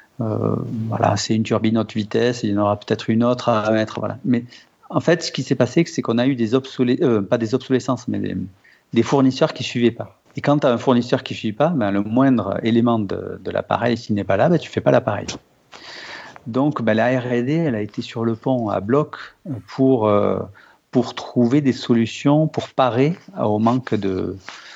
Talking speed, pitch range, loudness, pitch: 225 wpm, 110-130 Hz, -20 LUFS, 120 Hz